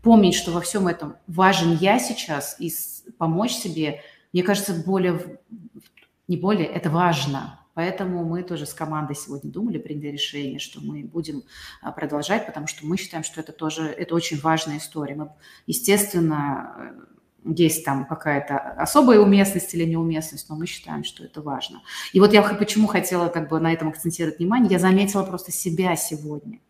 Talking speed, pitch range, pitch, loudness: 165 wpm, 155-190 Hz, 170 Hz, -22 LUFS